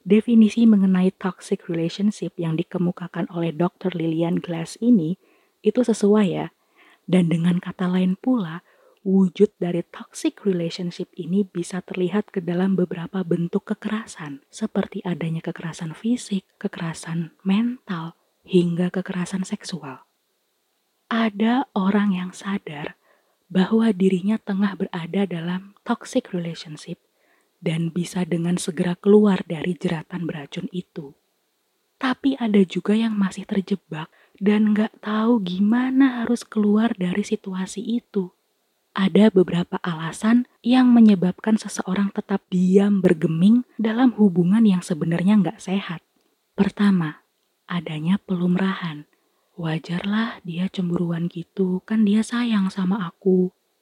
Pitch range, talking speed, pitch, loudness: 175-210 Hz, 115 wpm, 190 Hz, -22 LUFS